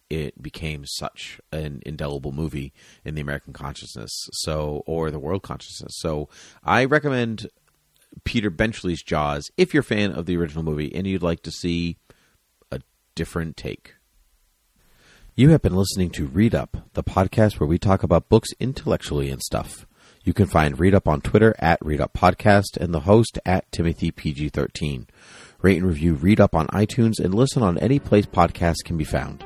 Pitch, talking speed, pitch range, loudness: 85 Hz, 180 wpm, 75-100 Hz, -22 LUFS